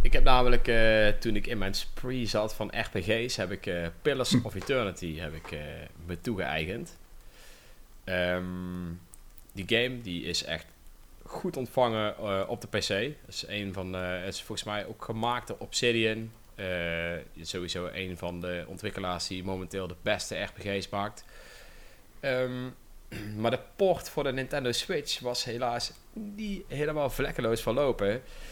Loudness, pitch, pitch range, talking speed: -31 LUFS, 105 Hz, 90-120 Hz, 145 wpm